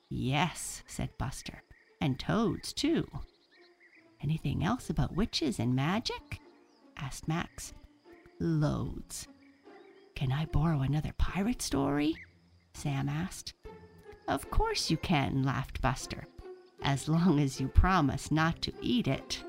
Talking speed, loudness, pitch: 115 wpm, -32 LUFS, 160 Hz